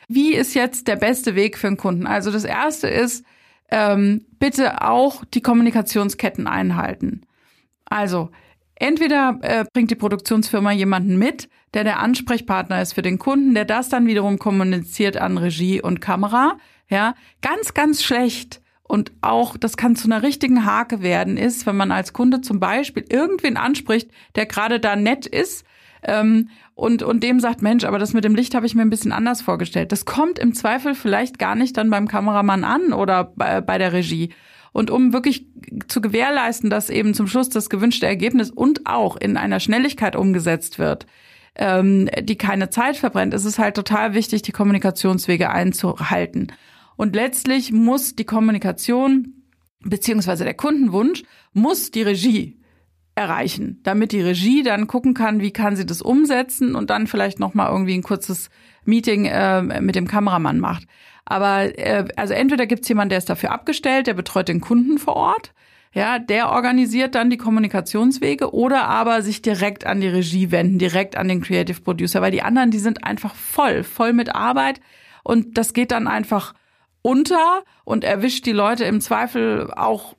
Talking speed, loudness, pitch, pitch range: 175 wpm, -19 LUFS, 220 Hz, 200-250 Hz